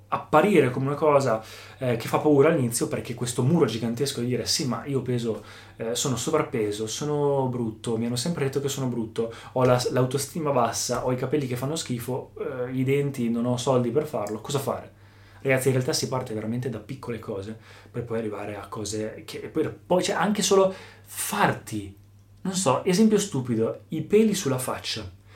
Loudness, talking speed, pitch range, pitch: -25 LUFS, 190 wpm, 110-140 Hz, 125 Hz